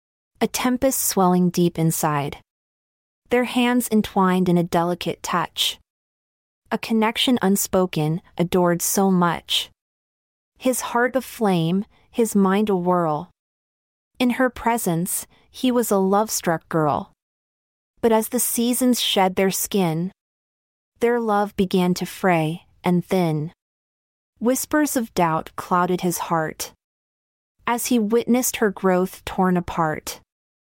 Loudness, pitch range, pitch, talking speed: -21 LUFS, 175-235 Hz, 195 Hz, 120 wpm